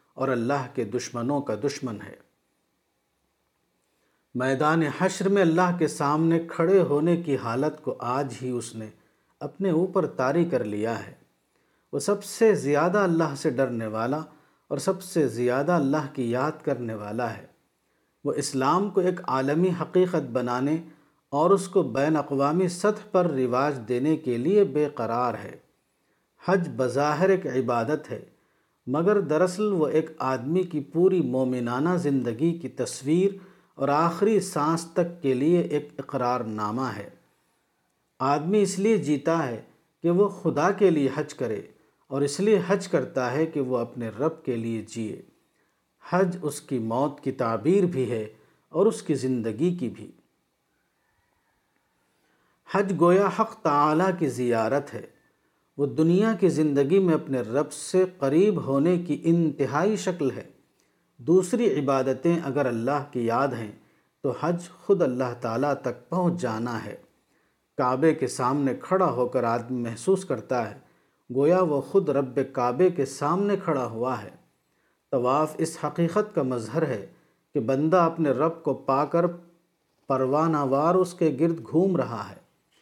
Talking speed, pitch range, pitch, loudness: 150 wpm, 130-175 Hz, 150 Hz, -25 LUFS